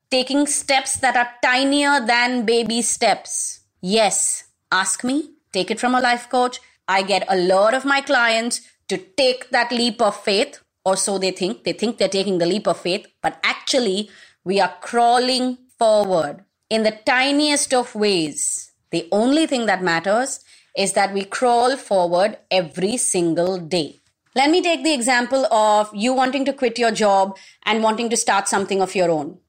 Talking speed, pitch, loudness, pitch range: 175 wpm, 220 Hz, -19 LUFS, 190-255 Hz